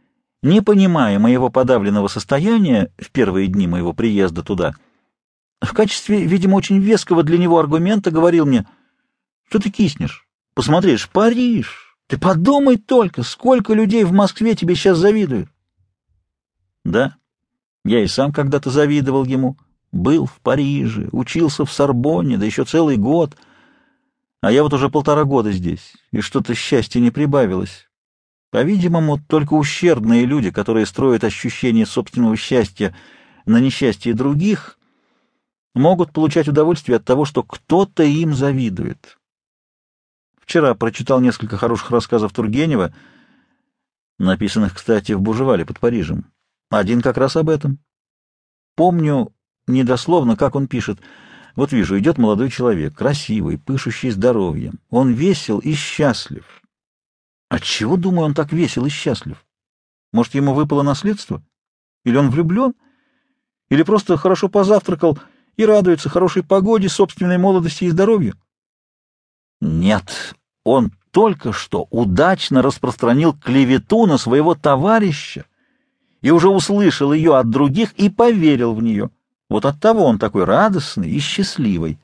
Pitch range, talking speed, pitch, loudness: 120-190 Hz, 125 wpm, 145 Hz, -16 LUFS